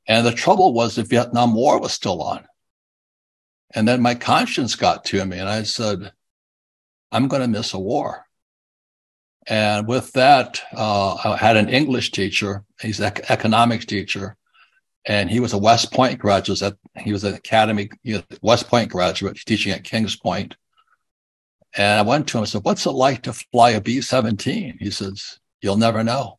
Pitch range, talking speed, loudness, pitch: 100-120 Hz, 180 wpm, -19 LUFS, 110 Hz